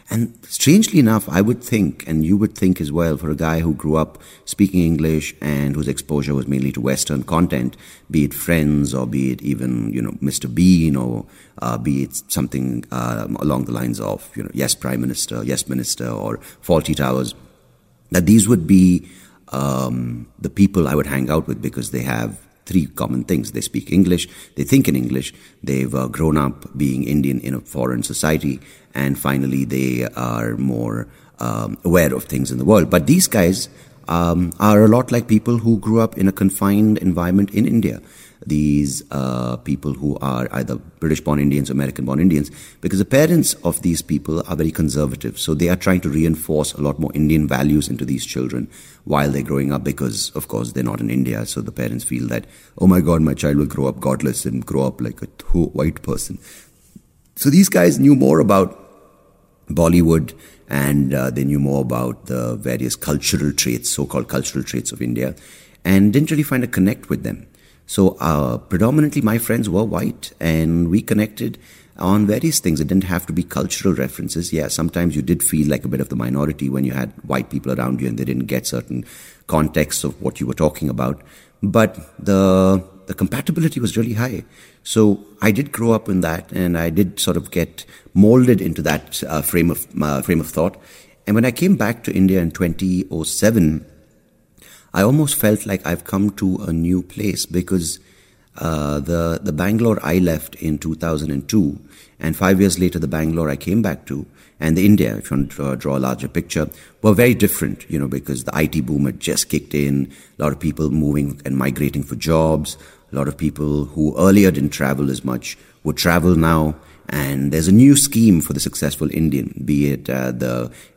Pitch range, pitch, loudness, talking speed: 70-95 Hz, 75 Hz, -18 LUFS, 195 wpm